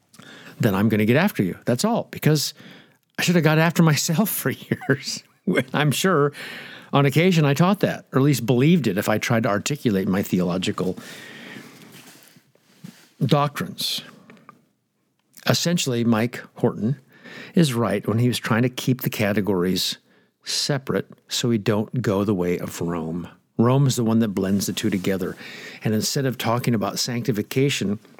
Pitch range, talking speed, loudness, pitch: 110-160 Hz, 160 wpm, -22 LUFS, 125 Hz